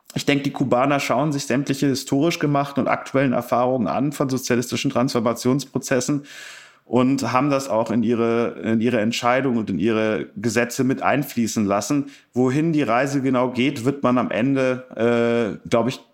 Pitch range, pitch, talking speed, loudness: 120-140 Hz, 130 Hz, 165 wpm, -21 LUFS